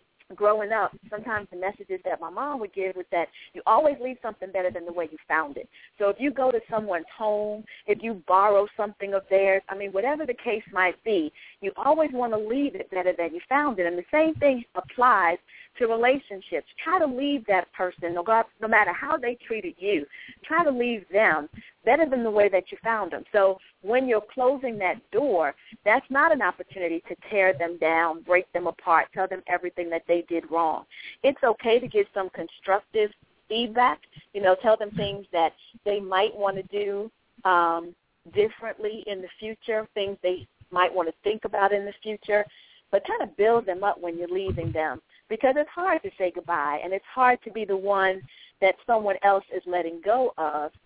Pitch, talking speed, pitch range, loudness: 200 Hz, 200 wpm, 180-230 Hz, -25 LUFS